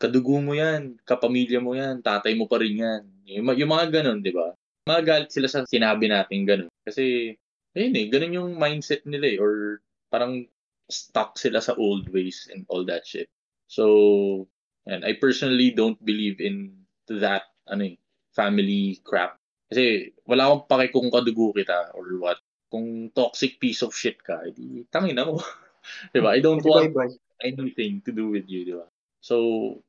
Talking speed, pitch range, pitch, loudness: 175 wpm, 100-135 Hz, 115 Hz, -24 LUFS